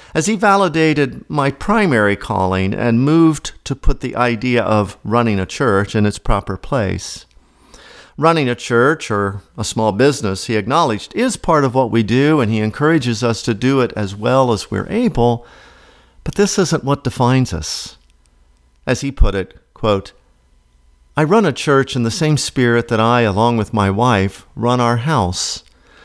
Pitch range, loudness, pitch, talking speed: 105-140 Hz, -16 LUFS, 120 Hz, 175 wpm